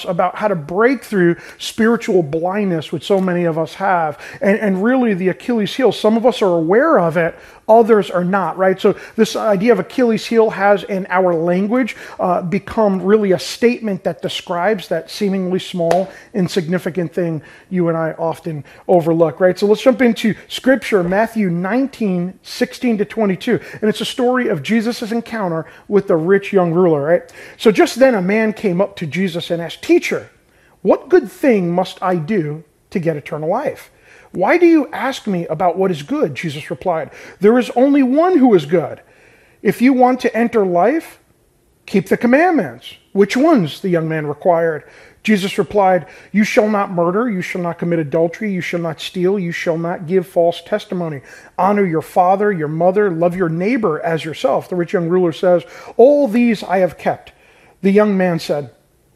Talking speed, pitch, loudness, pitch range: 185 wpm, 190 Hz, -16 LUFS, 175-220 Hz